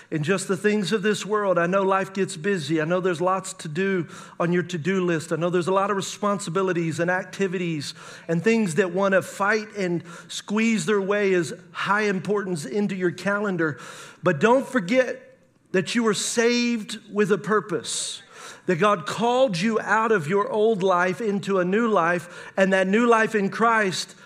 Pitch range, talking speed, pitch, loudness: 180-210 Hz, 190 wpm, 195 Hz, -23 LUFS